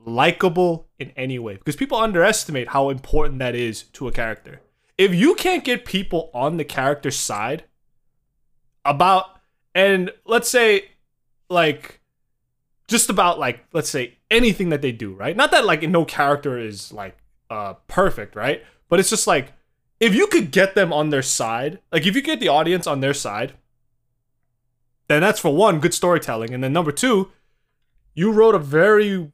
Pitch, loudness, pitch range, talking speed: 150 Hz, -19 LUFS, 130-195 Hz, 170 wpm